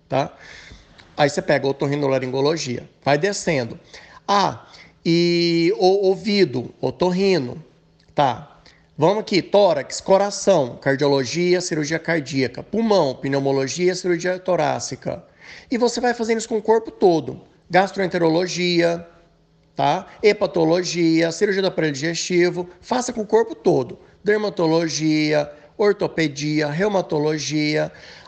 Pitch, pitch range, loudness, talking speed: 170 Hz, 150-195 Hz, -20 LUFS, 105 wpm